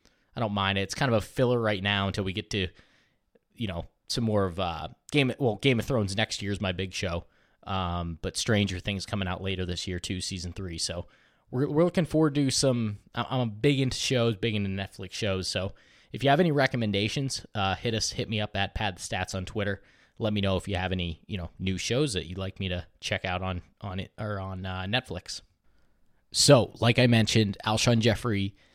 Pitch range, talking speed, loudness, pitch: 95-115 Hz, 230 wpm, -28 LUFS, 100 Hz